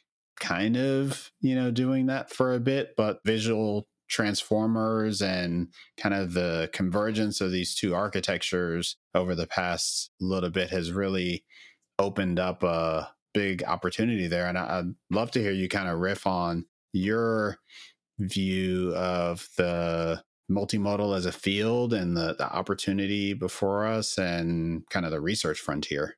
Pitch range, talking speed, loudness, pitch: 90-105 Hz, 145 wpm, -28 LUFS, 95 Hz